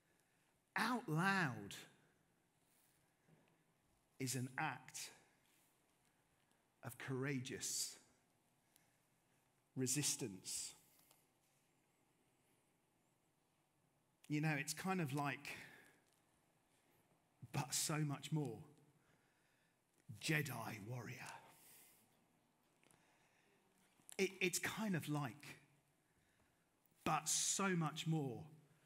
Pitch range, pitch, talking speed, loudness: 135-160 Hz, 150 Hz, 60 wpm, -43 LUFS